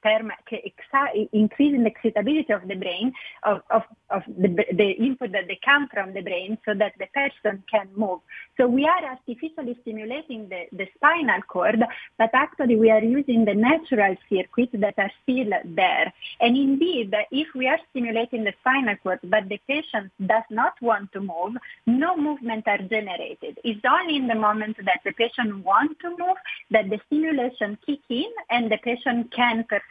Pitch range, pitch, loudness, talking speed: 210-270 Hz, 230 Hz, -23 LUFS, 175 wpm